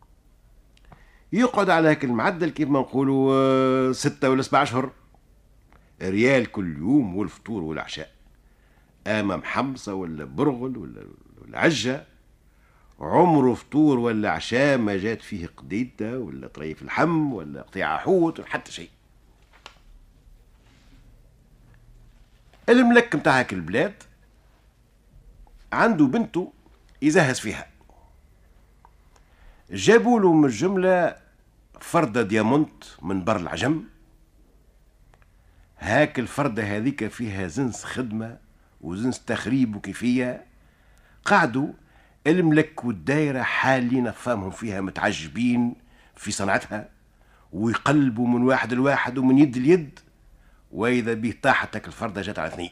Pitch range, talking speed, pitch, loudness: 105-140 Hz, 100 wpm, 125 Hz, -23 LUFS